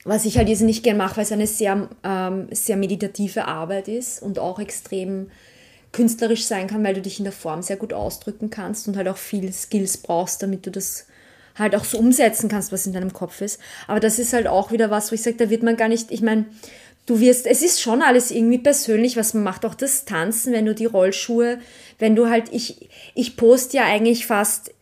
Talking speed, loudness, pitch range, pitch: 230 wpm, -20 LUFS, 195-235 Hz, 215 Hz